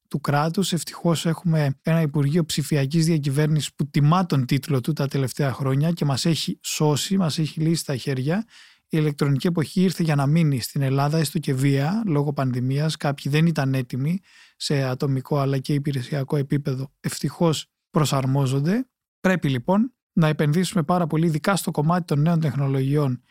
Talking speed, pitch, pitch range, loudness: 160 wpm, 155 Hz, 140-170 Hz, -23 LUFS